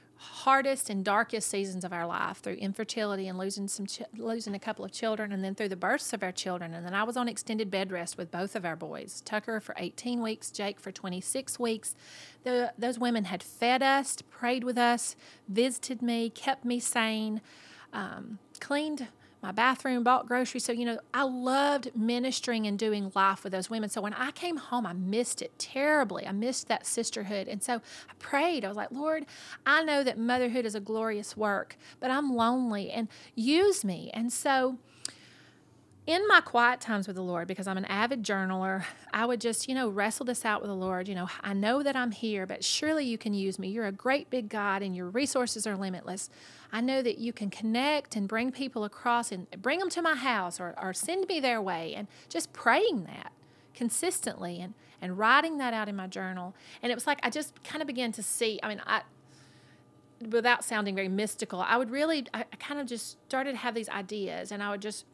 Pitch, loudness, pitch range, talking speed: 230 Hz, -31 LUFS, 200-255 Hz, 215 wpm